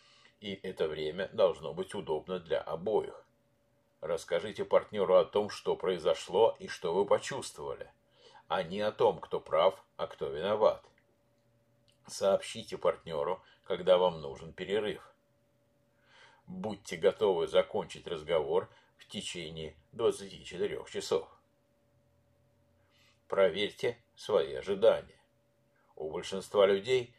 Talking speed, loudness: 105 wpm, -32 LUFS